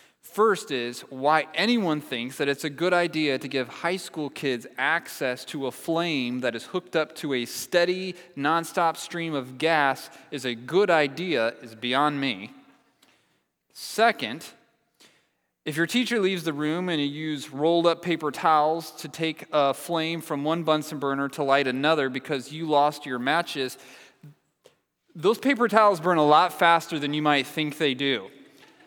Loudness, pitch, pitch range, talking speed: -25 LUFS, 155 Hz, 140-170 Hz, 165 wpm